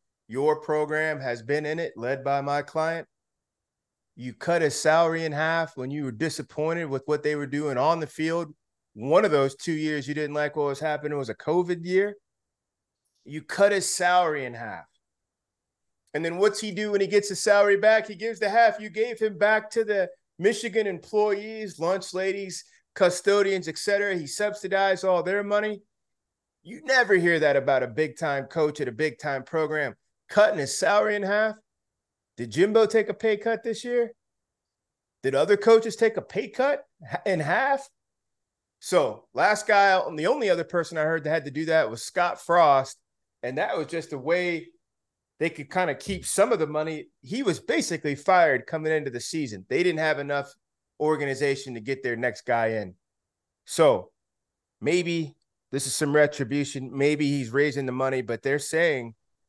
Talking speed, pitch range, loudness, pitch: 185 wpm, 140-200 Hz, -25 LUFS, 160 Hz